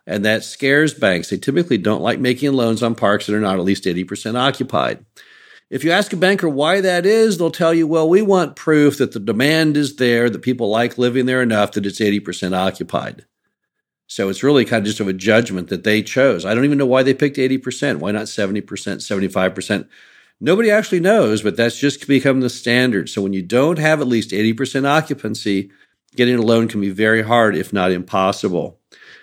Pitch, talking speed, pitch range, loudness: 120 Hz, 205 wpm, 105-145 Hz, -17 LUFS